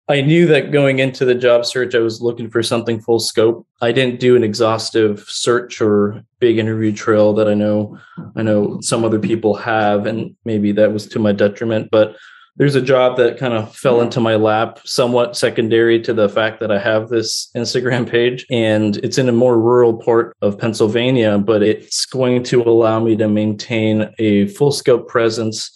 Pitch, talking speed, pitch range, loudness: 115 Hz, 195 wpm, 110-120 Hz, -15 LUFS